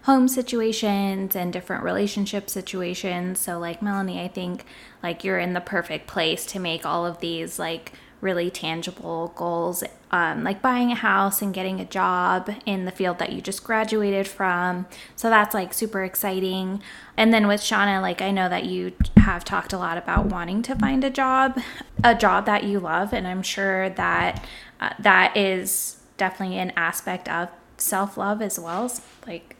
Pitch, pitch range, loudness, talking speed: 195 Hz, 180-210 Hz, -23 LUFS, 180 wpm